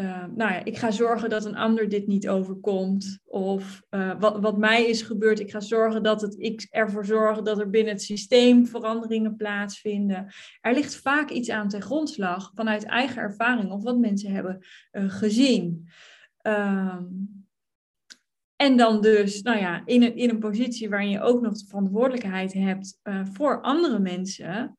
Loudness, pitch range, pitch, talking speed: -24 LUFS, 195-230 Hz, 215 Hz, 170 wpm